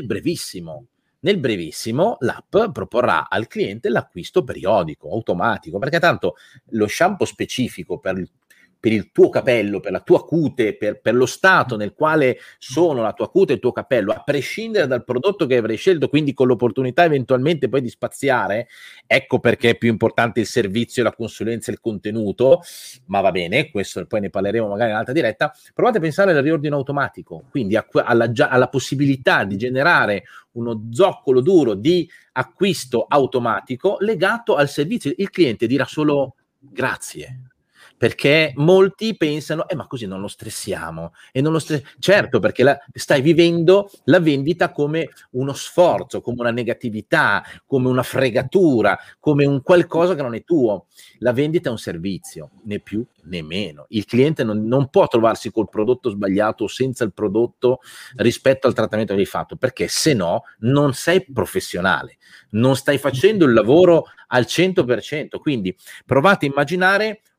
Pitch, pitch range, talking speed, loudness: 135 Hz, 115-170 Hz, 165 wpm, -19 LUFS